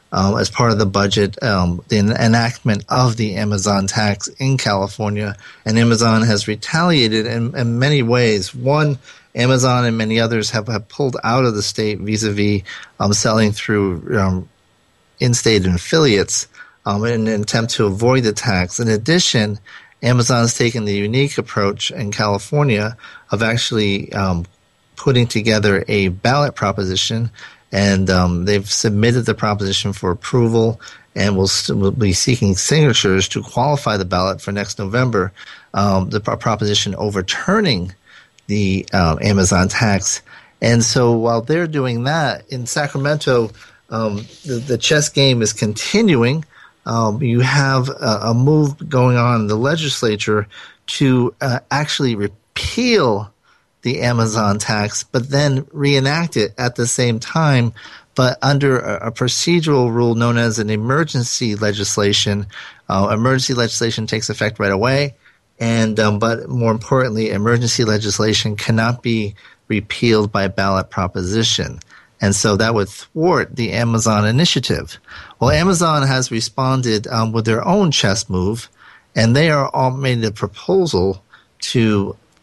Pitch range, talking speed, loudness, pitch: 105-125 Hz, 145 wpm, -17 LUFS, 115 Hz